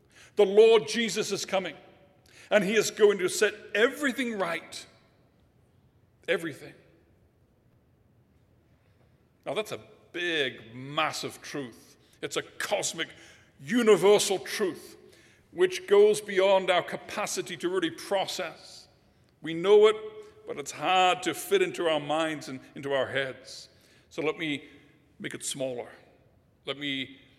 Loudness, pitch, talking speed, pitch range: -27 LUFS, 185 Hz, 125 wpm, 135-220 Hz